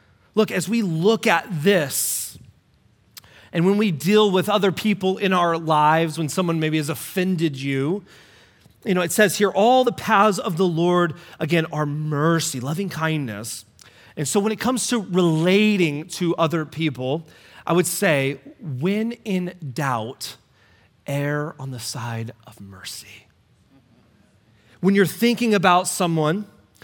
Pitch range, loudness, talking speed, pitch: 135-190 Hz, -21 LUFS, 145 wpm, 165 Hz